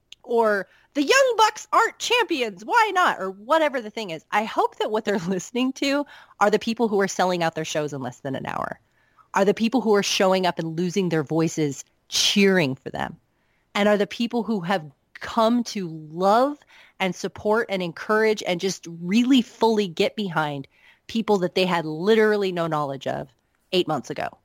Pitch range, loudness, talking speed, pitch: 170-230 Hz, -23 LUFS, 190 wpm, 200 Hz